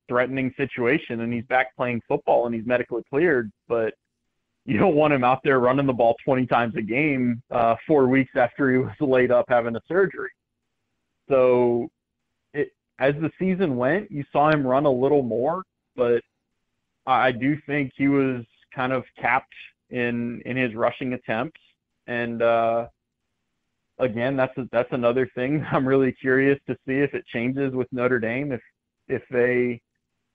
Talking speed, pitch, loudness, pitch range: 170 wpm, 125 Hz, -23 LUFS, 120-140 Hz